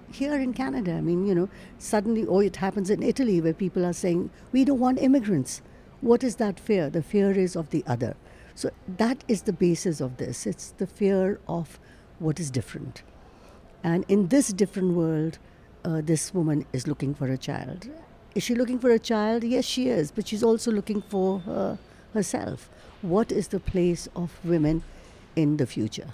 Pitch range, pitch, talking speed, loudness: 170-225 Hz, 195 Hz, 190 wpm, -26 LUFS